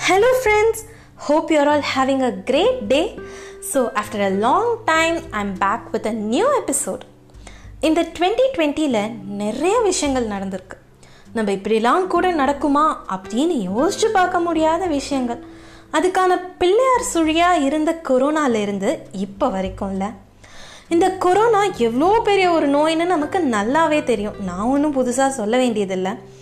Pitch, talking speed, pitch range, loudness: 295 Hz, 125 wpm, 225-360 Hz, -19 LUFS